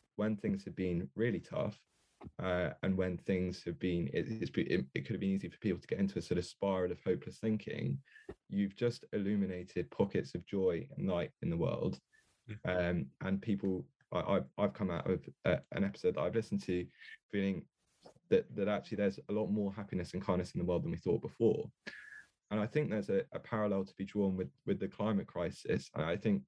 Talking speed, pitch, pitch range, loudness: 210 wpm, 100 Hz, 90-105 Hz, -37 LUFS